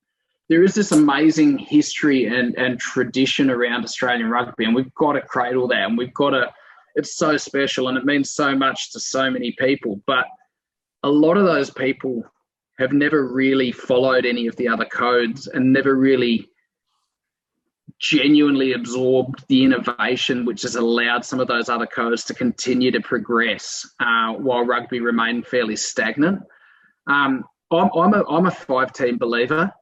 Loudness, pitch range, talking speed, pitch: -19 LUFS, 120-145 Hz, 165 wpm, 130 Hz